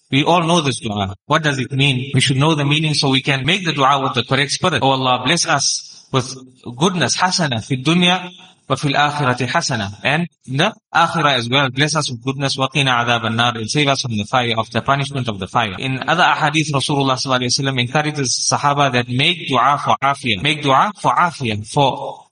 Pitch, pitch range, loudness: 135 Hz, 125-150 Hz, -16 LUFS